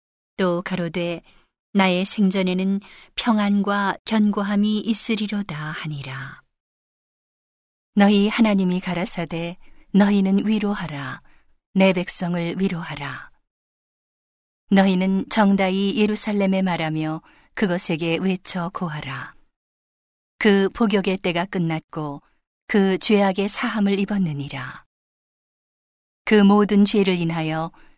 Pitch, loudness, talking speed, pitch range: 190 Hz, -21 LUFS, 220 characters per minute, 170-205 Hz